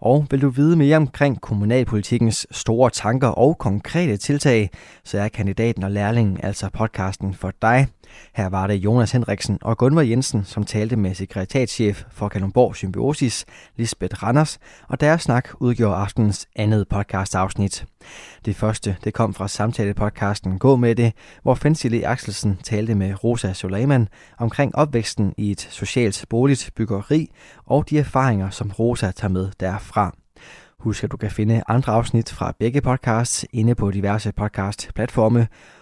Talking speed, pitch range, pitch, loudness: 150 wpm, 100-125 Hz, 110 Hz, -21 LUFS